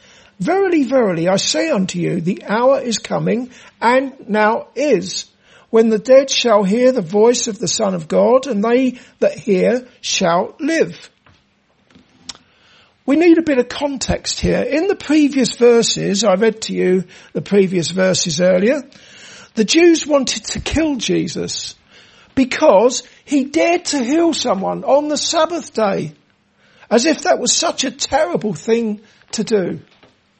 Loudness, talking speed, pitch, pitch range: -16 LUFS, 150 wpm, 240 Hz, 210-285 Hz